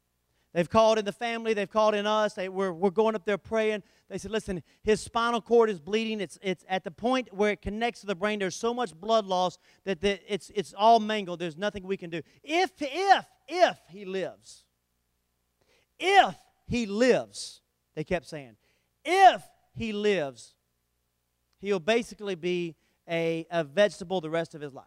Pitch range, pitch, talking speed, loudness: 170-220 Hz, 200 Hz, 185 wpm, -27 LUFS